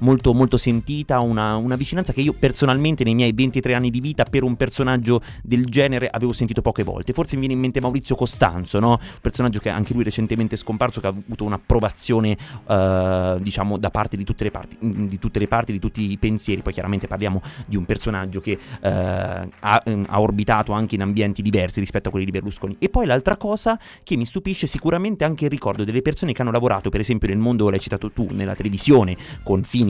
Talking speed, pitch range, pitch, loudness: 215 wpm, 100-125 Hz, 115 Hz, -21 LUFS